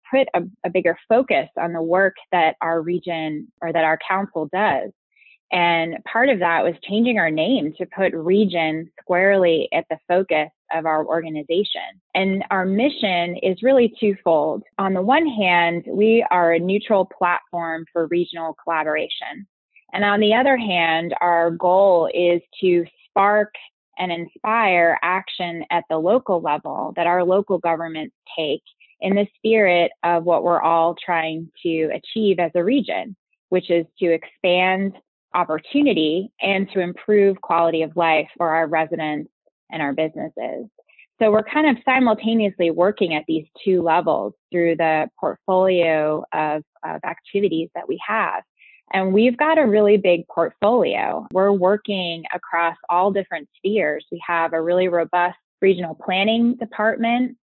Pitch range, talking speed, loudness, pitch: 165-200 Hz, 150 wpm, -20 LUFS, 175 Hz